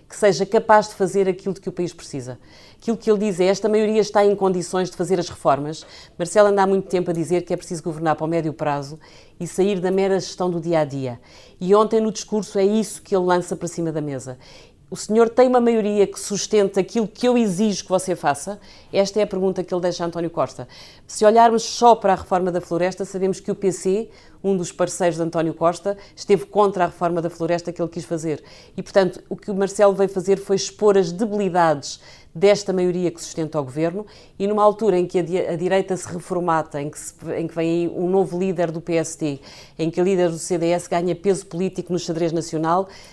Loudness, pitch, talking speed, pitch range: -21 LUFS, 185 Hz, 225 wpm, 170-200 Hz